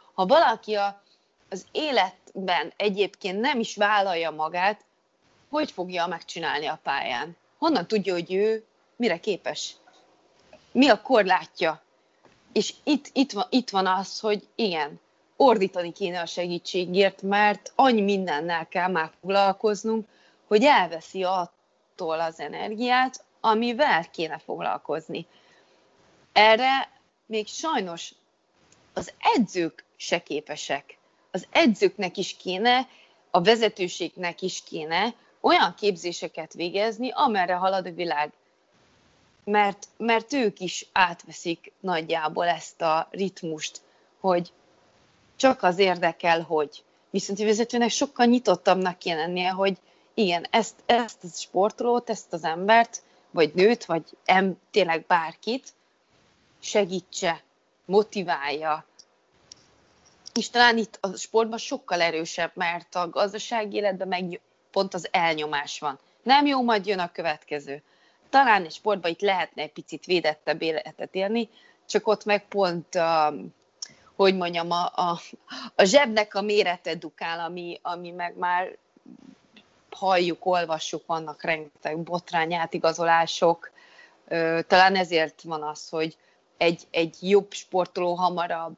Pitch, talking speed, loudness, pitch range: 185 Hz, 120 wpm, -25 LUFS, 170-215 Hz